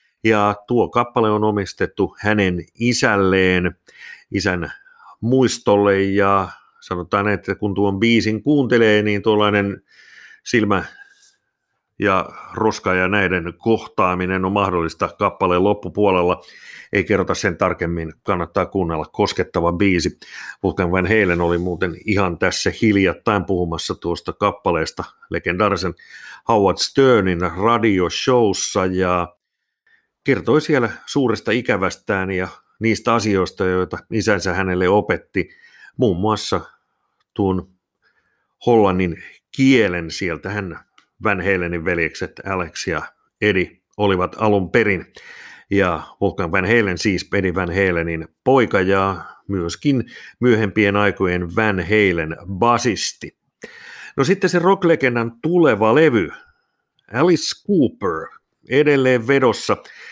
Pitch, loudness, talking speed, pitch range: 100 Hz, -18 LUFS, 105 wpm, 90-115 Hz